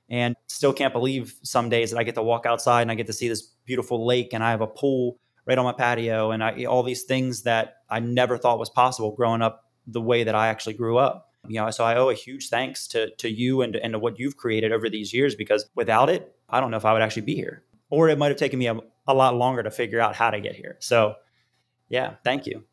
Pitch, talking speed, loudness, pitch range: 120 Hz, 270 wpm, -24 LUFS, 115-125 Hz